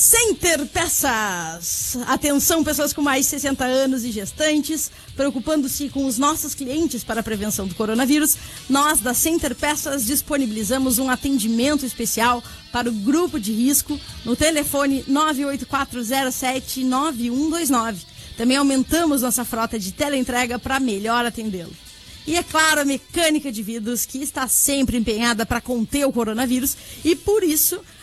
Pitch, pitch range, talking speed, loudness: 270 Hz, 240-295 Hz, 135 wpm, -20 LUFS